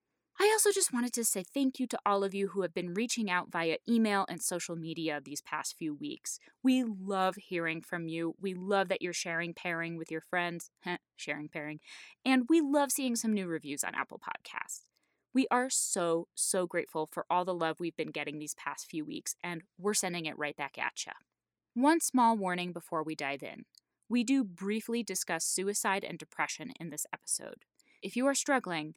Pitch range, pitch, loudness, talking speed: 165-235 Hz, 185 Hz, -33 LUFS, 200 wpm